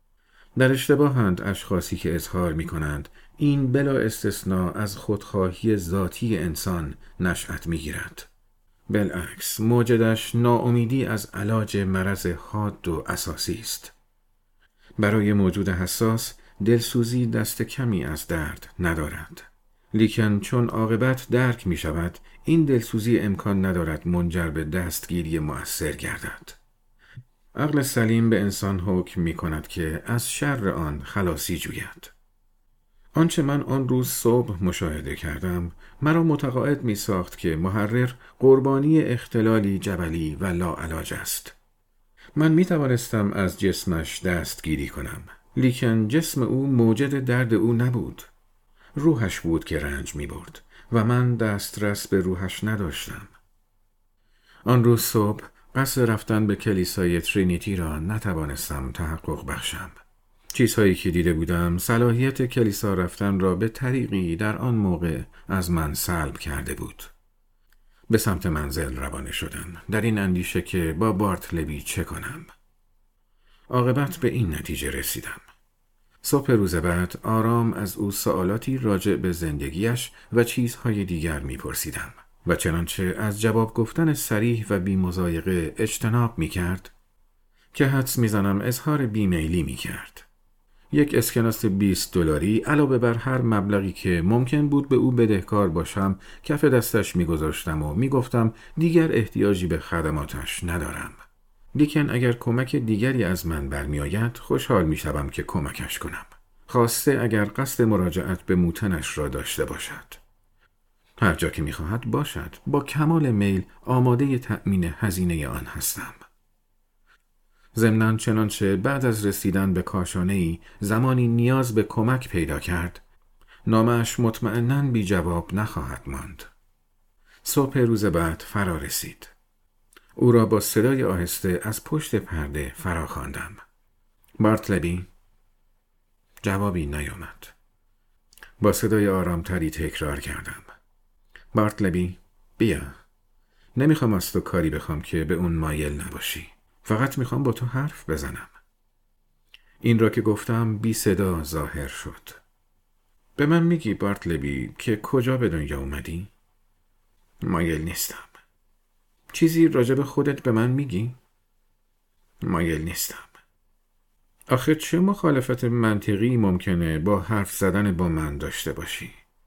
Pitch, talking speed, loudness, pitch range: 100 Hz, 125 wpm, -24 LUFS, 85-120 Hz